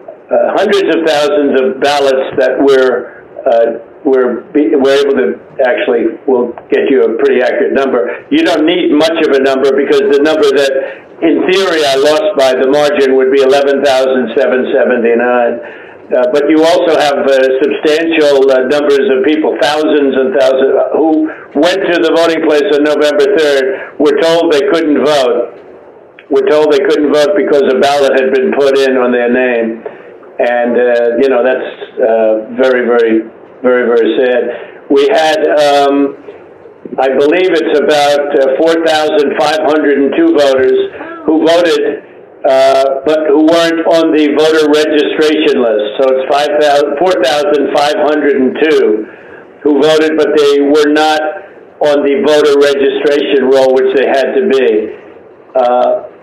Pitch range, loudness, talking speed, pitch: 135-165 Hz, -9 LUFS, 150 wpm, 145 Hz